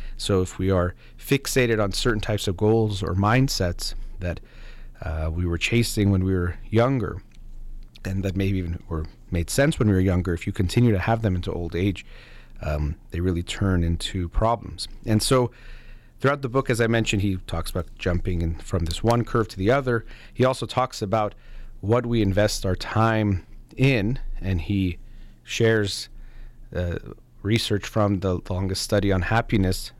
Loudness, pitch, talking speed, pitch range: -24 LUFS, 100 Hz, 175 wpm, 90-115 Hz